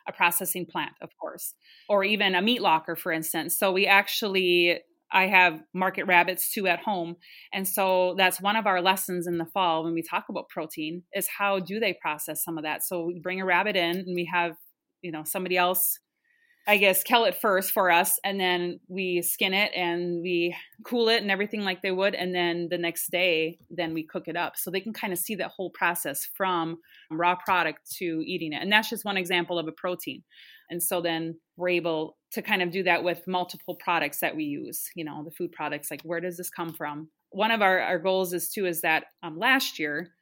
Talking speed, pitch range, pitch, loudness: 225 wpm, 170-195 Hz, 180 Hz, -26 LUFS